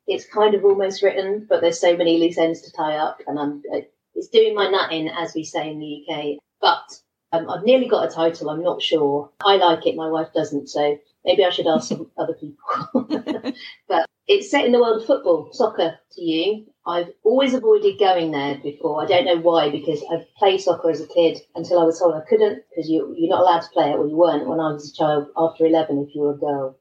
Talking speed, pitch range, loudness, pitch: 240 wpm, 155-215 Hz, -20 LUFS, 170 Hz